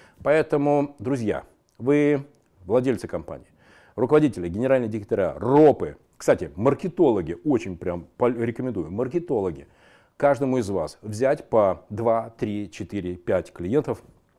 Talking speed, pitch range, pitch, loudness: 105 wpm, 105-140 Hz, 120 Hz, -24 LUFS